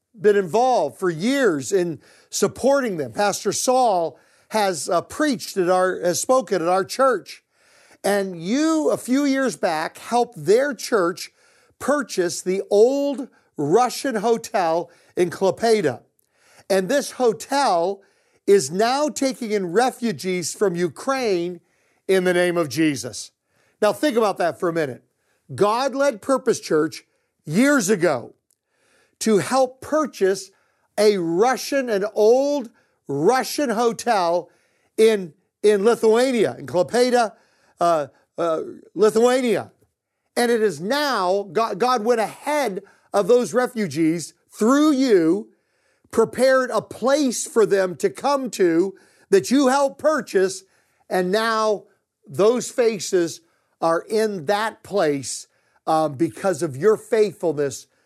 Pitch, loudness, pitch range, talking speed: 215 Hz, -21 LUFS, 185-255 Hz, 120 wpm